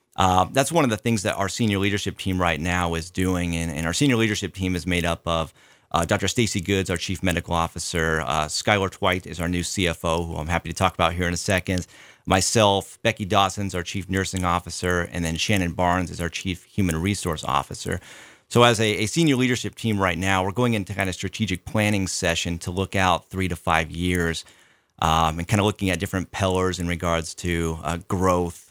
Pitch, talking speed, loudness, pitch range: 90 Hz, 215 wpm, -23 LUFS, 85-100 Hz